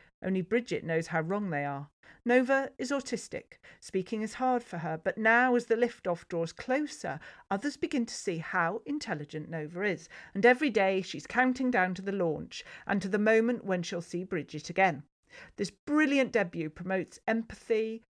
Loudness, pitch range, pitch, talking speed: -31 LUFS, 175-245 Hz, 200 Hz, 175 wpm